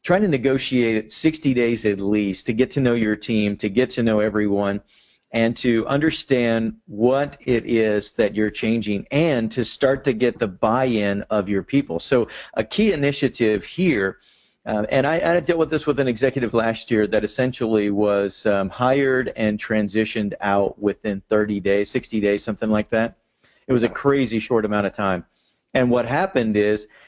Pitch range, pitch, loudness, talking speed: 105-130 Hz, 115 Hz, -21 LUFS, 185 wpm